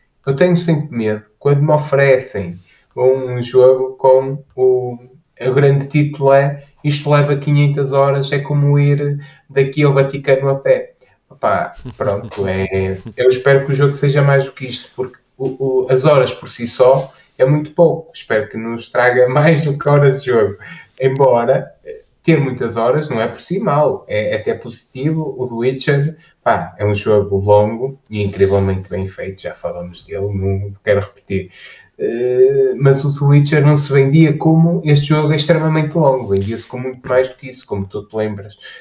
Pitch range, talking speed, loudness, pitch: 120-145 Hz, 180 wpm, -15 LUFS, 135 Hz